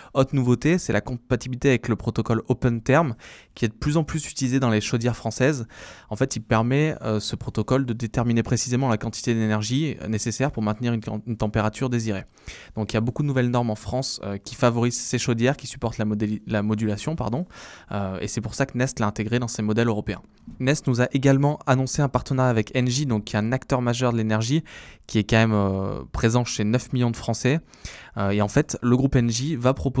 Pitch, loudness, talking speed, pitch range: 120 Hz, -24 LUFS, 225 wpm, 110-130 Hz